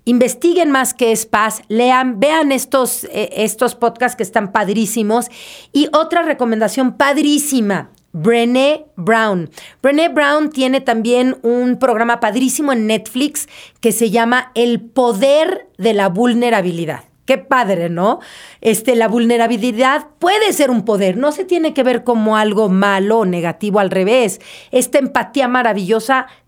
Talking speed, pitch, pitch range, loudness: 140 wpm, 240 Hz, 220-265 Hz, -15 LUFS